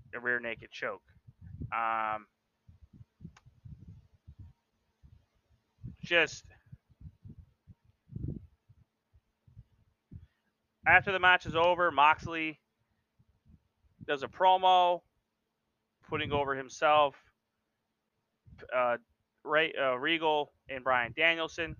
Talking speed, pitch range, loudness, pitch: 70 wpm, 110-160 Hz, -29 LUFS, 125 Hz